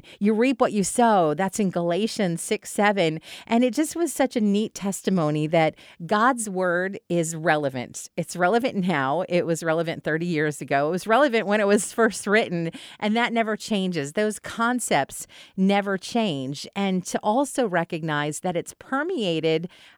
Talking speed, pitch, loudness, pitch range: 165 wpm, 195 Hz, -24 LUFS, 165-225 Hz